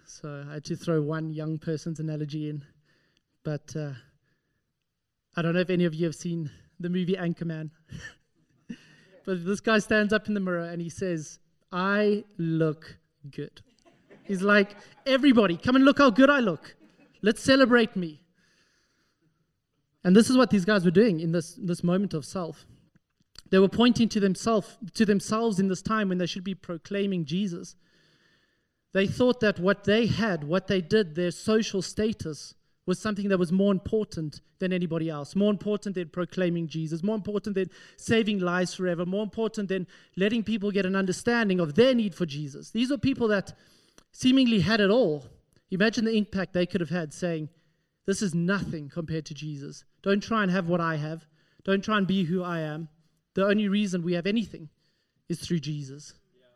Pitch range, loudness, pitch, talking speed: 160-210 Hz, -26 LUFS, 180 Hz, 180 wpm